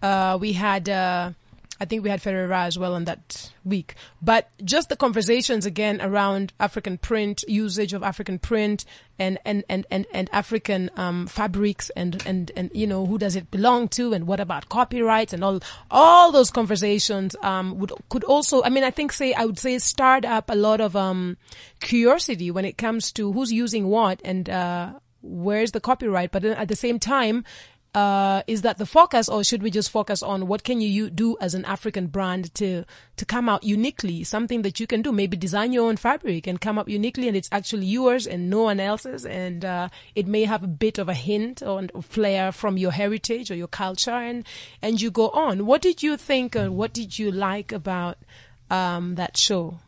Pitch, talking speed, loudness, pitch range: 205 Hz, 210 wpm, -23 LUFS, 185-225 Hz